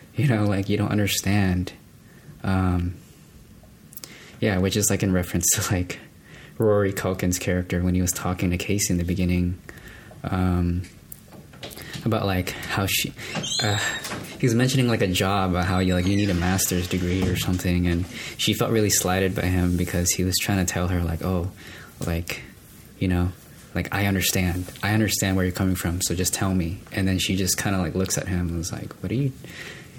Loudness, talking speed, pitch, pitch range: -24 LUFS, 195 wpm, 95 Hz, 90-100 Hz